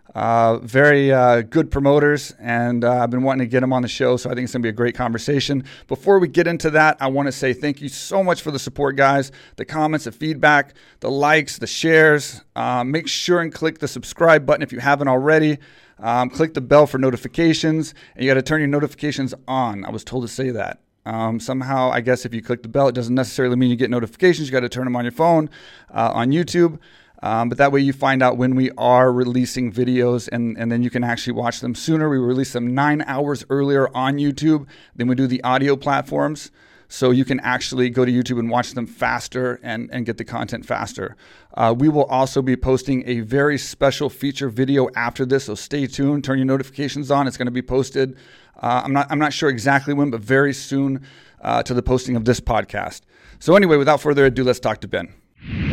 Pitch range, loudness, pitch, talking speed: 125-145 Hz, -19 LUFS, 130 Hz, 225 wpm